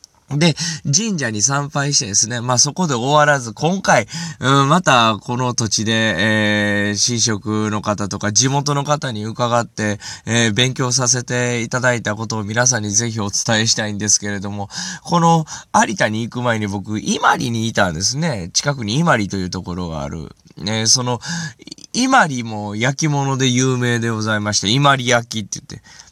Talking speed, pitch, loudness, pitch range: 340 characters per minute, 120 Hz, -17 LUFS, 105-140 Hz